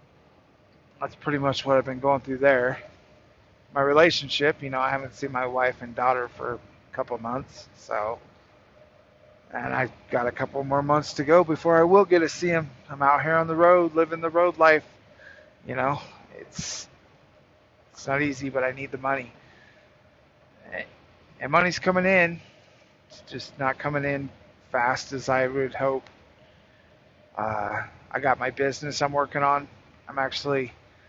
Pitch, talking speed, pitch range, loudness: 135 Hz, 165 wpm, 125-150 Hz, -24 LUFS